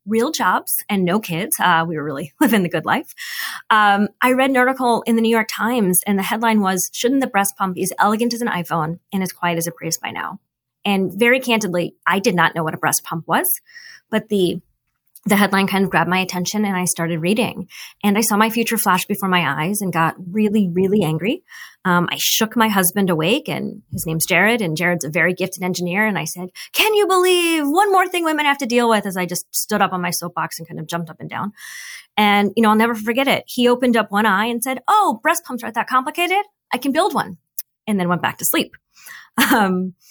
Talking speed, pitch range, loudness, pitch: 240 wpm, 180-245 Hz, -18 LUFS, 205 Hz